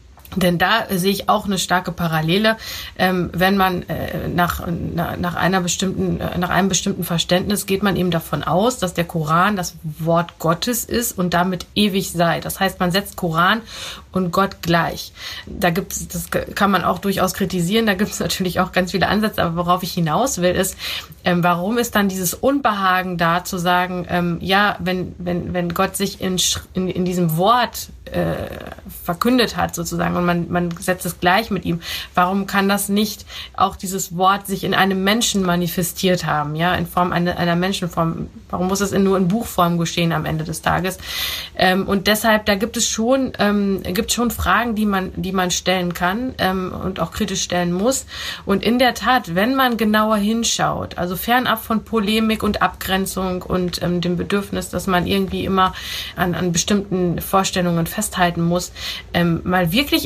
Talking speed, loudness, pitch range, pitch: 185 wpm, -19 LUFS, 175-200 Hz, 185 Hz